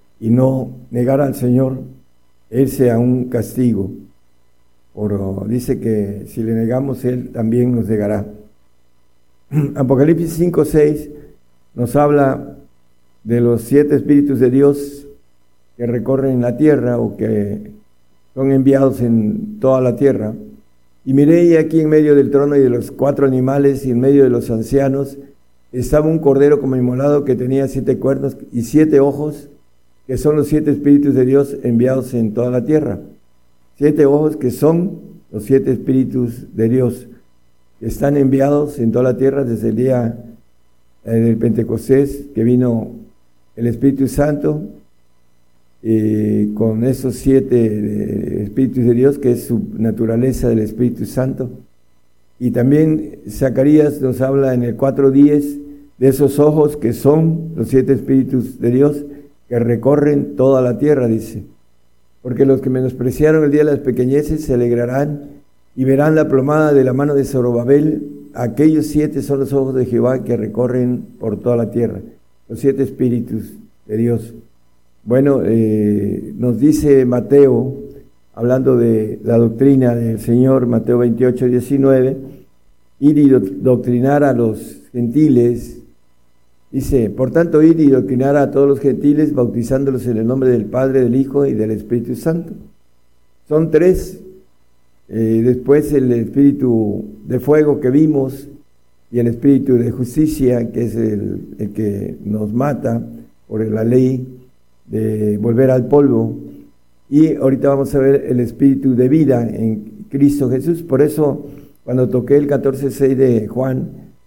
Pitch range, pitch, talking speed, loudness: 110-140 Hz, 125 Hz, 145 wpm, -15 LUFS